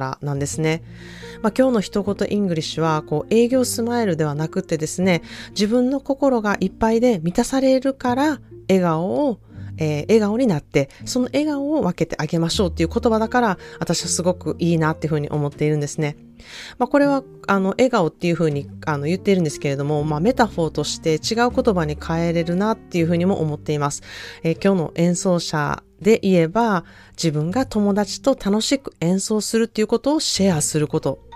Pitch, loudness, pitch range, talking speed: 180 Hz, -20 LUFS, 155-230 Hz, 410 characters per minute